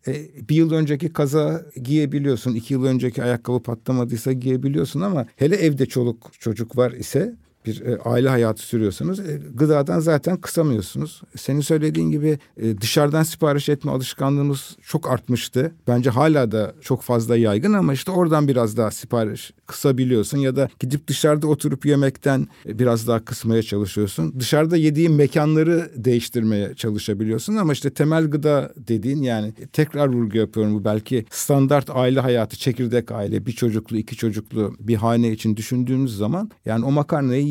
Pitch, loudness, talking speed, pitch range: 130 Hz, -21 LUFS, 145 wpm, 115-150 Hz